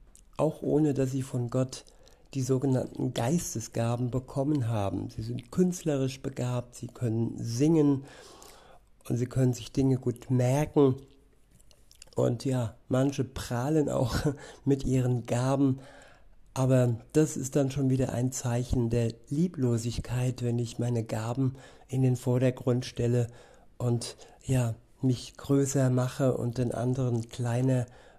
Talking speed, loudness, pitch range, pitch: 130 wpm, -29 LUFS, 120-135 Hz, 125 Hz